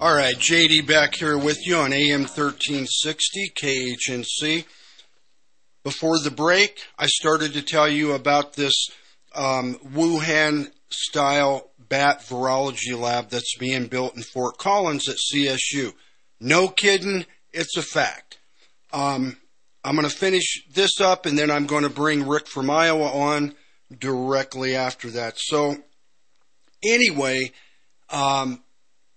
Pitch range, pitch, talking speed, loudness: 130-155 Hz, 145 Hz, 130 wpm, -21 LUFS